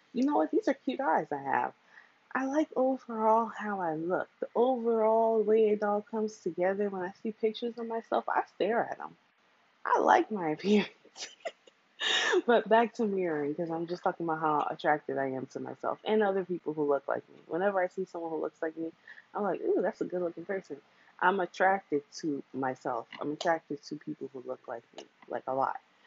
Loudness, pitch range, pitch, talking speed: -31 LUFS, 160-225 Hz, 195 Hz, 205 wpm